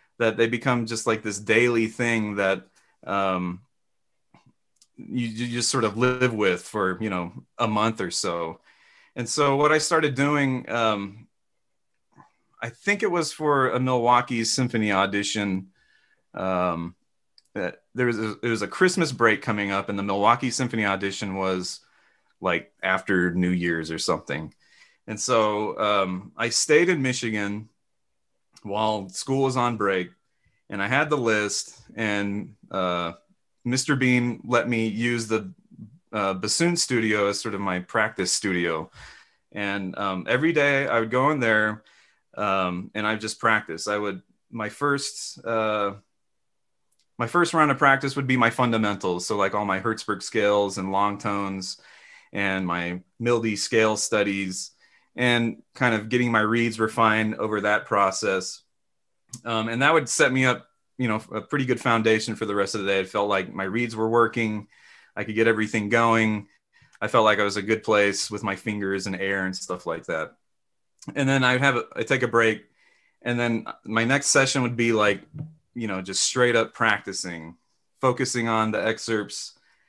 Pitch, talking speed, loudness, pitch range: 110 Hz, 170 wpm, -24 LUFS, 100-125 Hz